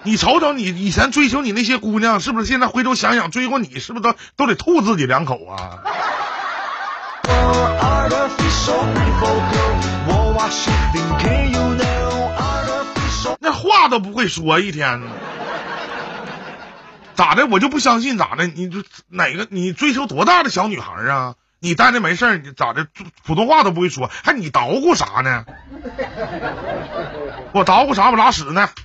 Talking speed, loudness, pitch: 200 characters per minute, -17 LUFS, 185 Hz